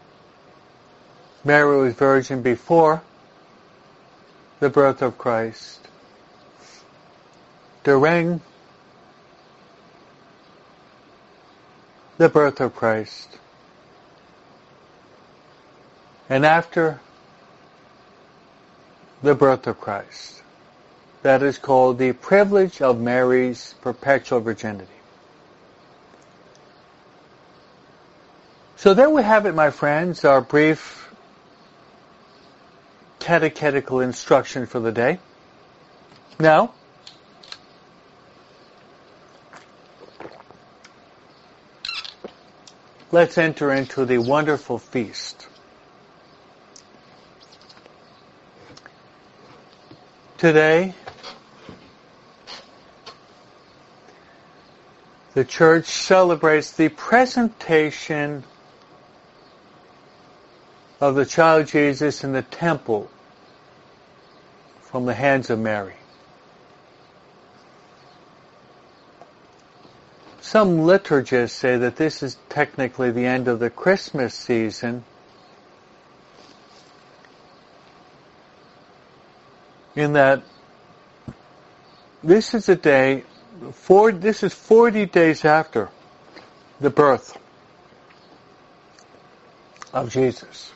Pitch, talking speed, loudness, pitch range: 140 Hz, 65 wpm, -19 LUFS, 125-160 Hz